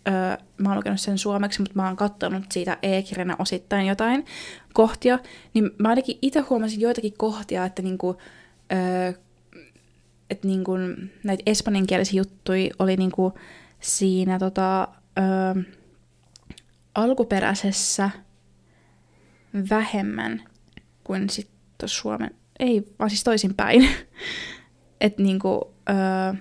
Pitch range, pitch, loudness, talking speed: 185-210 Hz, 195 Hz, -24 LUFS, 105 wpm